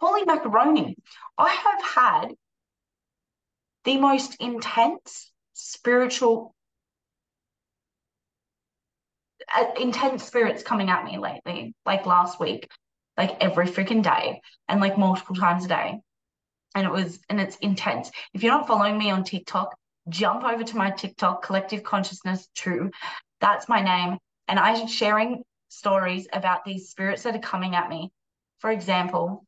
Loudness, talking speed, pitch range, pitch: -24 LUFS, 135 wpm, 185-230 Hz, 200 Hz